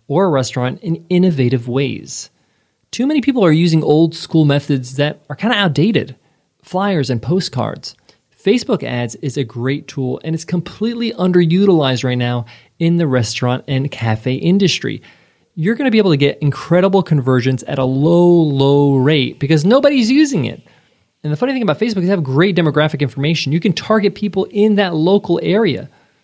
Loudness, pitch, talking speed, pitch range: -15 LUFS, 160 Hz, 180 wpm, 135-190 Hz